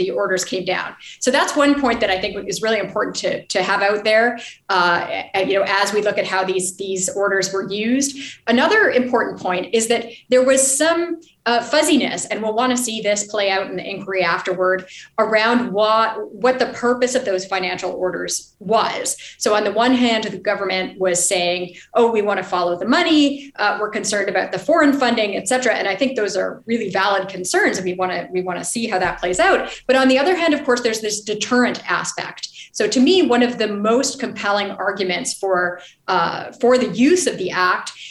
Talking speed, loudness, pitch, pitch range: 215 wpm, -18 LUFS, 215 Hz, 190-245 Hz